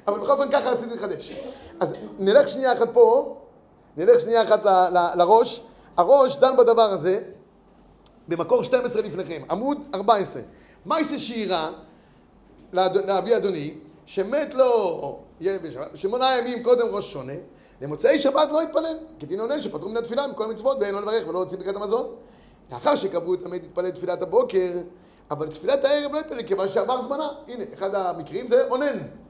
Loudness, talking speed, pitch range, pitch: -22 LUFS, 160 wpm, 195-295 Hz, 235 Hz